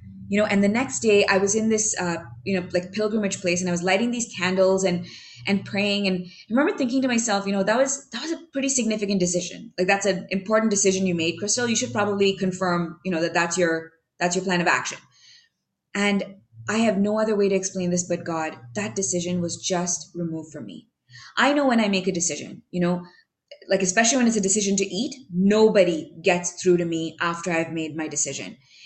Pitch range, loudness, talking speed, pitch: 175-215 Hz, -23 LUFS, 225 wpm, 190 Hz